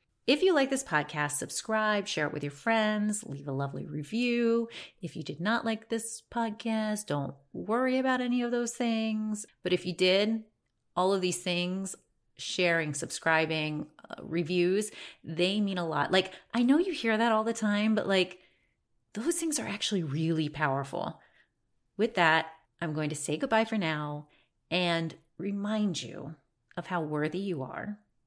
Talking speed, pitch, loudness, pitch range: 170 wpm, 190 Hz, -30 LUFS, 160-225 Hz